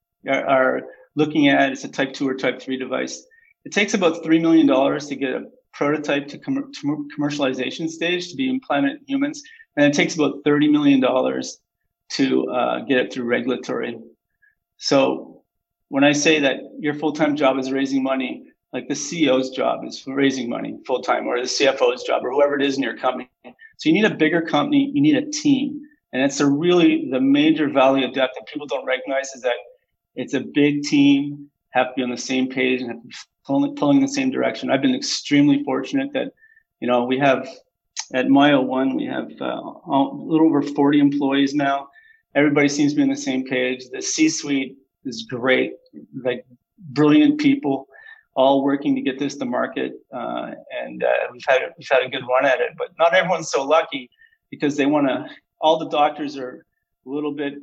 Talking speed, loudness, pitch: 195 wpm, -20 LUFS, 145 Hz